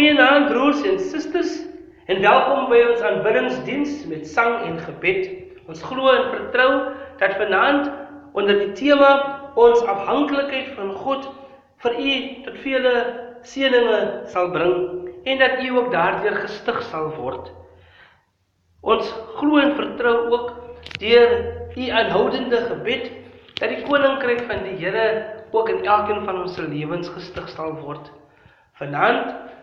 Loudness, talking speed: -20 LUFS, 140 wpm